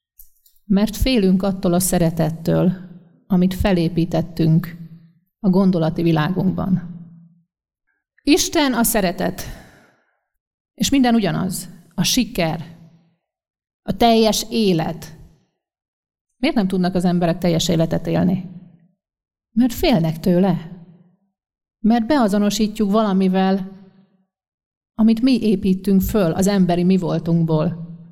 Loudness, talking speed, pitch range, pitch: -18 LUFS, 90 wpm, 170-205 Hz, 185 Hz